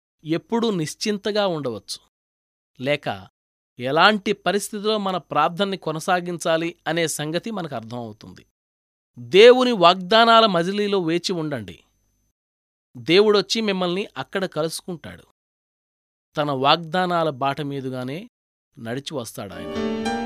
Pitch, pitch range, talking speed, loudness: 165 Hz, 125-195 Hz, 80 wpm, -21 LUFS